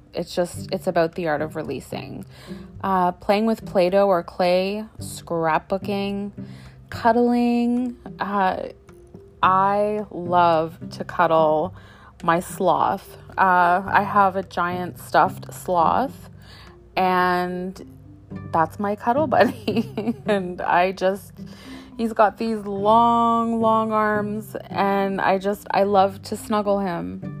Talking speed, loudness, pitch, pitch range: 115 wpm, -21 LUFS, 190 Hz, 175-210 Hz